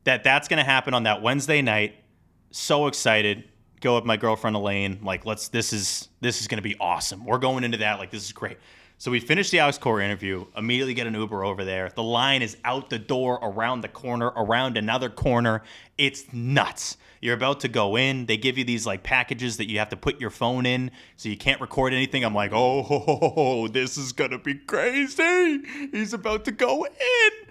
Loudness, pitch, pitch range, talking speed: -24 LUFS, 120 Hz, 110-135 Hz, 210 wpm